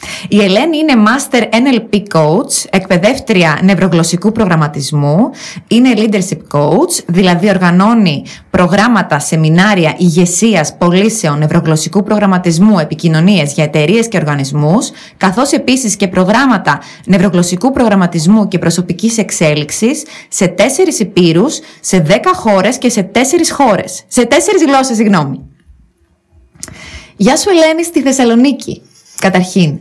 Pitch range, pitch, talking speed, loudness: 170-230 Hz, 195 Hz, 105 wpm, -10 LUFS